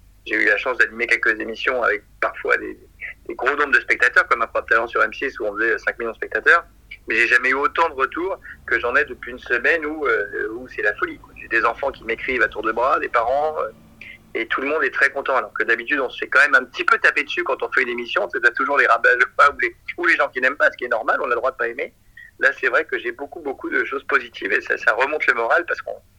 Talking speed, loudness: 285 wpm, -19 LUFS